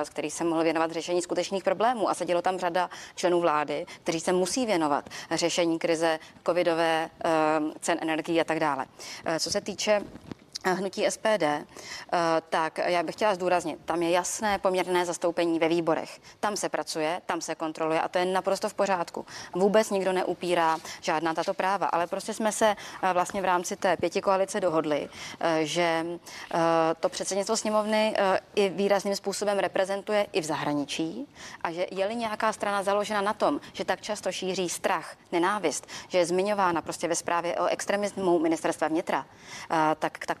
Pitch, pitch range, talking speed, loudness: 180 Hz, 165-195 Hz, 160 wpm, -27 LUFS